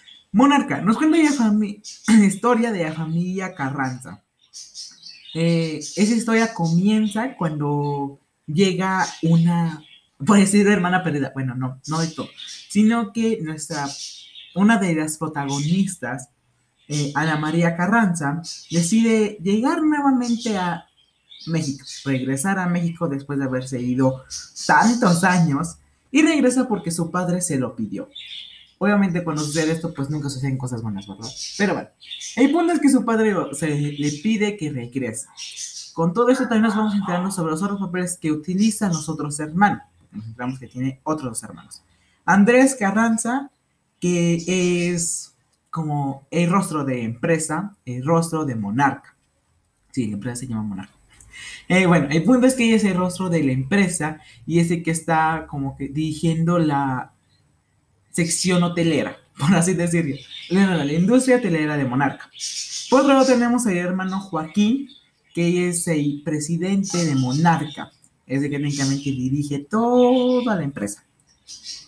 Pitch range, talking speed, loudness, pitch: 145-205 Hz, 150 wpm, -21 LUFS, 170 Hz